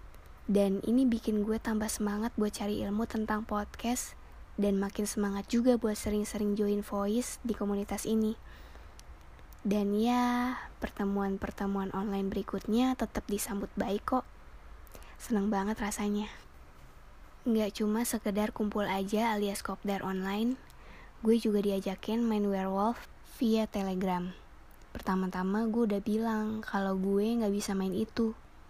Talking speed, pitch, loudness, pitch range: 125 wpm, 205 Hz, -32 LUFS, 195-220 Hz